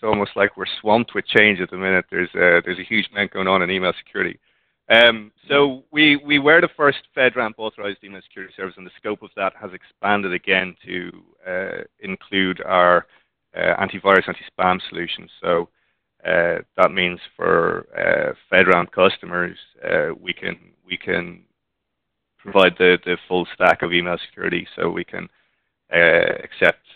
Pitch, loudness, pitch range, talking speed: 105 Hz, -18 LUFS, 90-140 Hz, 165 wpm